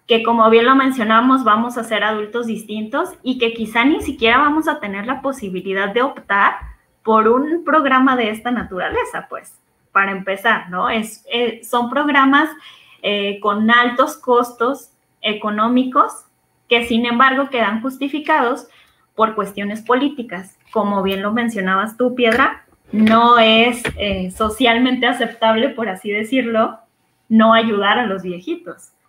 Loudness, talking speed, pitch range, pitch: -16 LUFS, 140 wpm, 215-260 Hz, 230 Hz